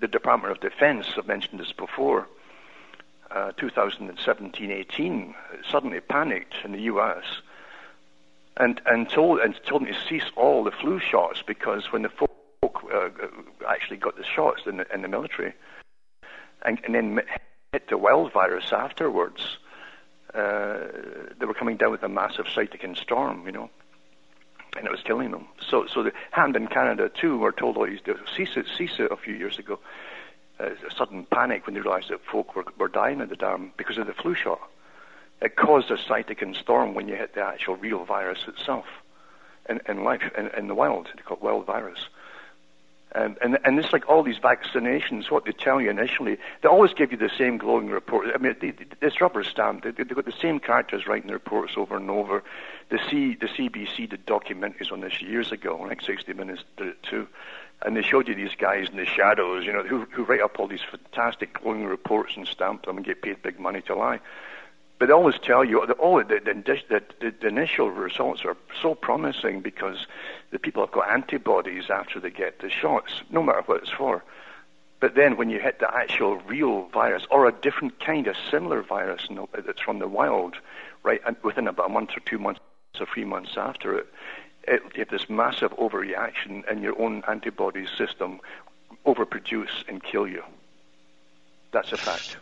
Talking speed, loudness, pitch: 190 wpm, -25 LUFS, 165 Hz